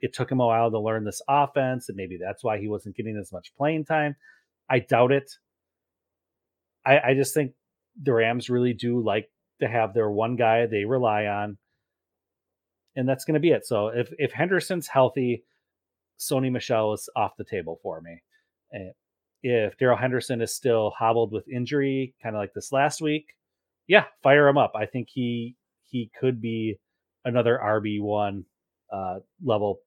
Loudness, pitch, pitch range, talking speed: -25 LUFS, 120 Hz, 110-135 Hz, 180 wpm